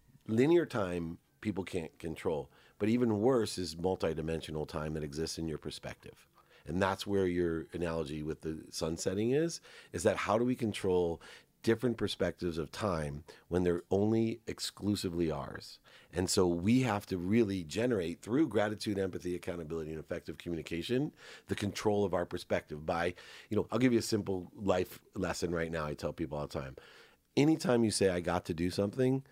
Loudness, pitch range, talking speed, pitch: -34 LUFS, 85-105 Hz, 175 wpm, 90 Hz